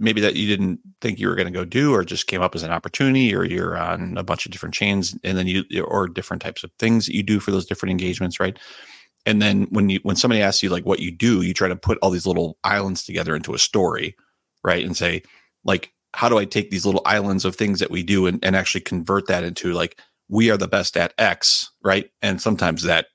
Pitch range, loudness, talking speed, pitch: 90-105 Hz, -21 LUFS, 255 wpm, 95 Hz